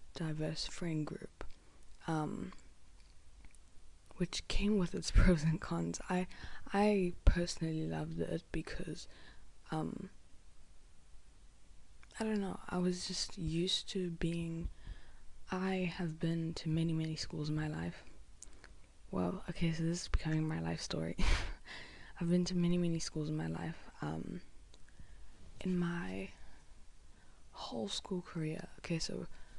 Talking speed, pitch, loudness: 130 wpm, 155 Hz, -38 LUFS